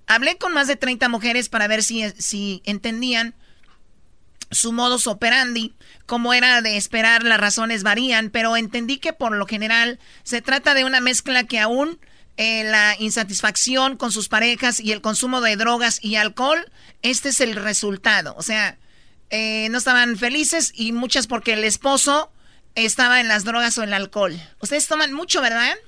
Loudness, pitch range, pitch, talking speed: -18 LUFS, 215-255 Hz, 235 Hz, 170 wpm